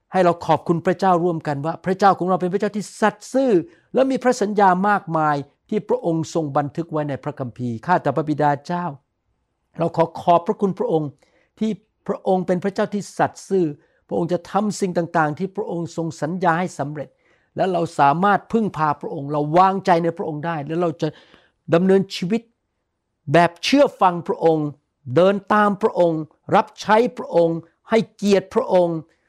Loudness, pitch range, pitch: -20 LUFS, 160-200 Hz, 175 Hz